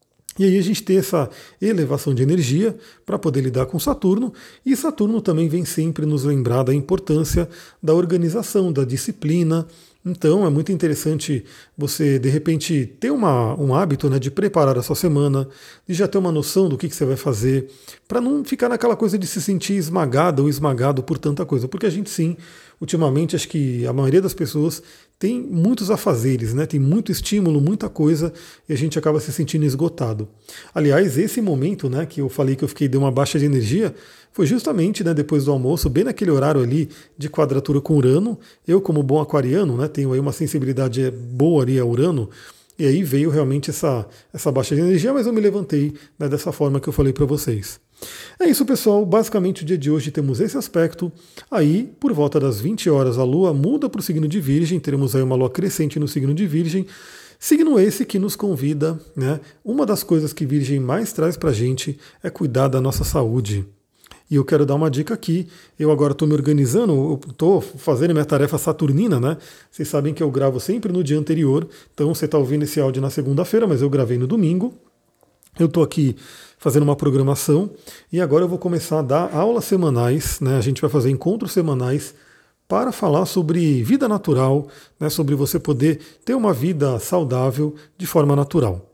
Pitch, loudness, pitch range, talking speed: 155 Hz, -19 LUFS, 140-180 Hz, 200 wpm